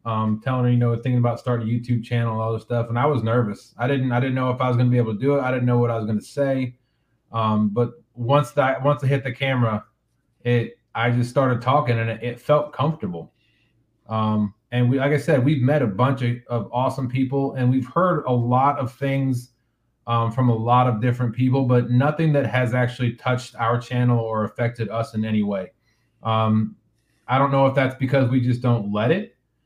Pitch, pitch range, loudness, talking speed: 125 Hz, 115-130 Hz, -22 LUFS, 235 wpm